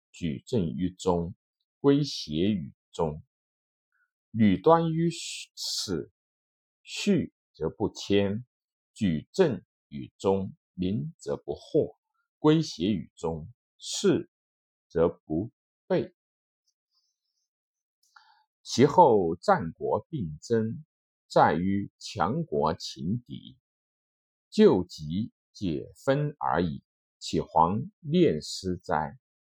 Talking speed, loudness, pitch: 110 characters per minute, -28 LUFS, 115 Hz